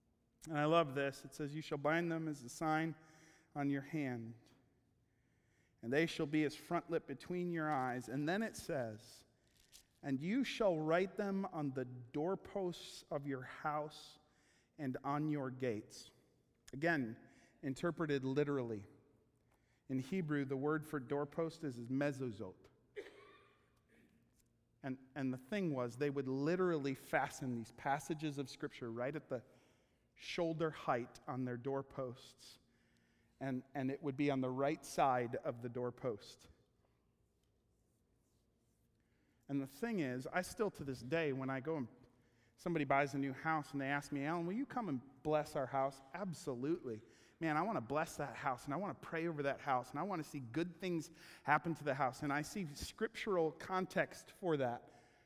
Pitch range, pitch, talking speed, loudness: 125-160 Hz, 140 Hz, 165 wpm, -41 LUFS